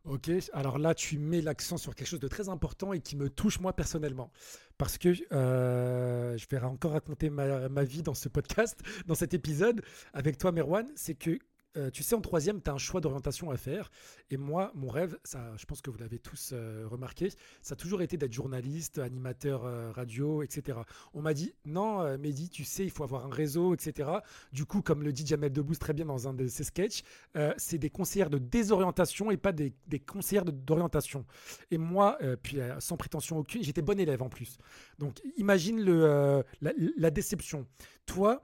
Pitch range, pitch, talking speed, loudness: 135-180 Hz, 150 Hz, 210 wpm, -33 LUFS